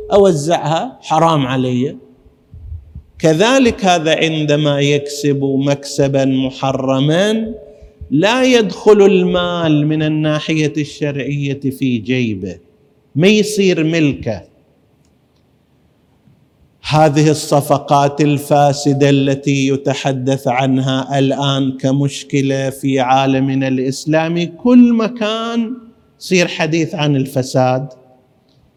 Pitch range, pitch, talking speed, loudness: 135-165 Hz, 145 Hz, 75 wpm, -14 LUFS